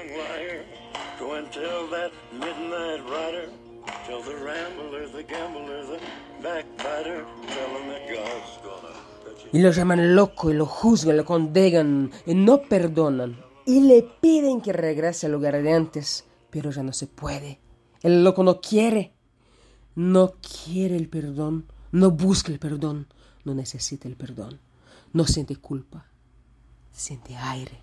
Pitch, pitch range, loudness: 150 Hz, 130-175 Hz, -23 LUFS